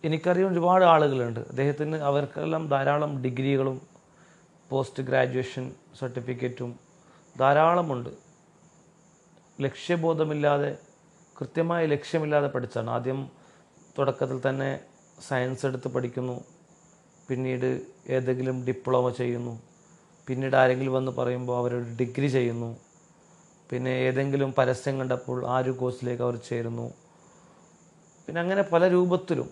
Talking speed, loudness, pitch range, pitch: 90 wpm, -27 LUFS, 130-170 Hz, 135 Hz